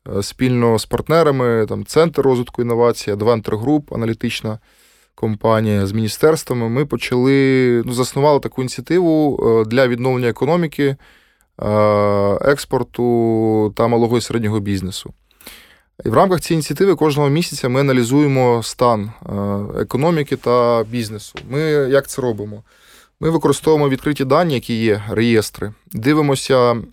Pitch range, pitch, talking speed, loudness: 110-140 Hz, 120 Hz, 120 wpm, -17 LUFS